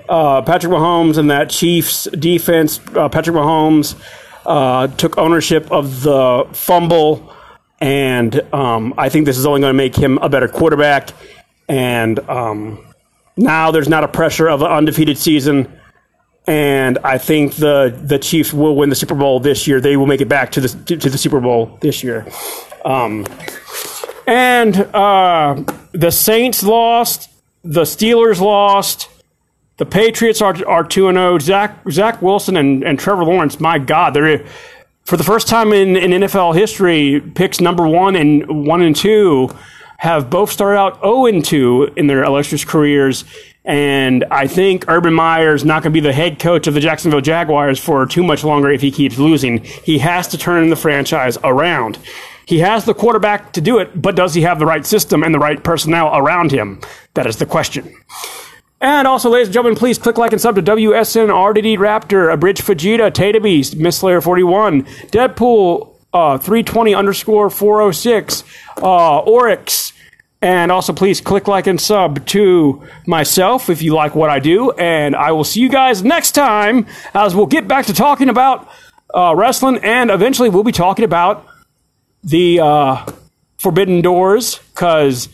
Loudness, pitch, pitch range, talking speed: -12 LUFS, 170 Hz, 145-205 Hz, 170 wpm